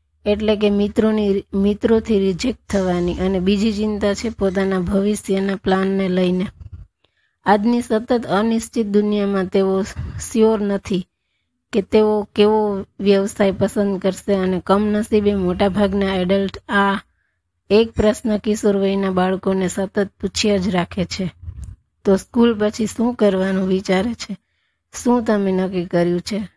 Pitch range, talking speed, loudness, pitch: 190-210 Hz, 120 wpm, -19 LUFS, 200 Hz